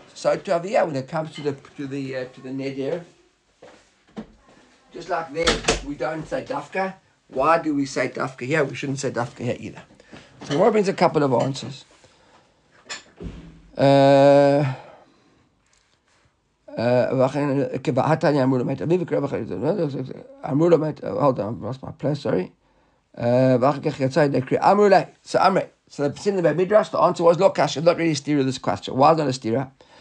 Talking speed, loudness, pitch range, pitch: 150 wpm, -21 LUFS, 130-160 Hz, 140 Hz